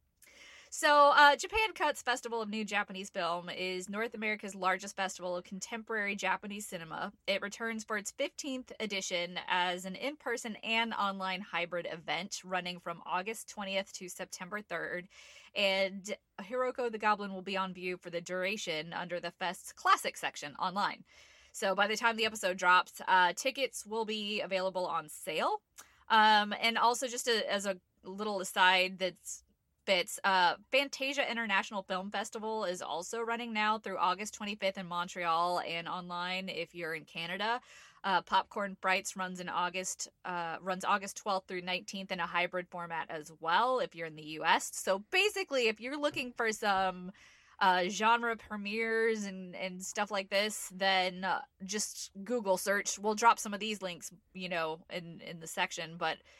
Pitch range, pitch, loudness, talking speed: 180-225 Hz, 195 Hz, -33 LUFS, 165 wpm